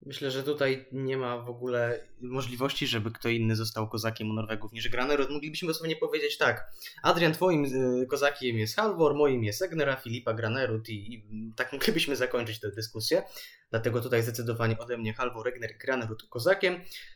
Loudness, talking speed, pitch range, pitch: -30 LUFS, 165 wpm, 115-145 Hz, 125 Hz